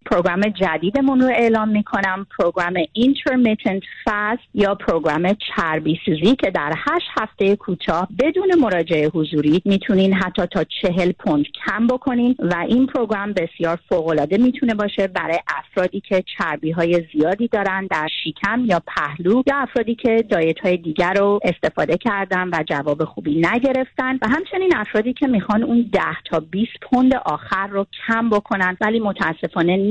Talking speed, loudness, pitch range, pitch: 150 wpm, -19 LUFS, 175-235 Hz, 200 Hz